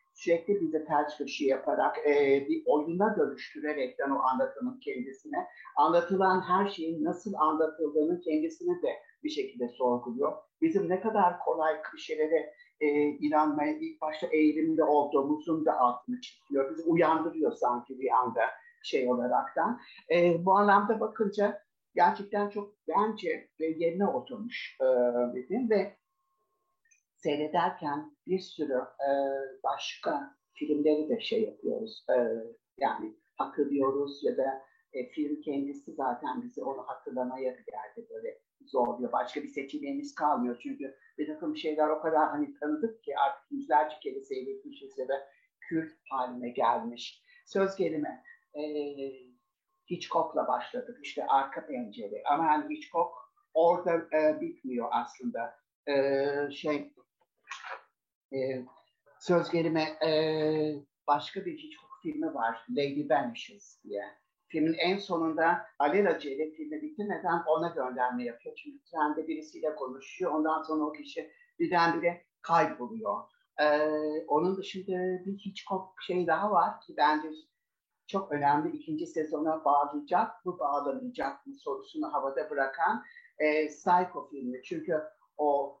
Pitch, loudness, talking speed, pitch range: 165 Hz, -31 LUFS, 120 wpm, 150-240 Hz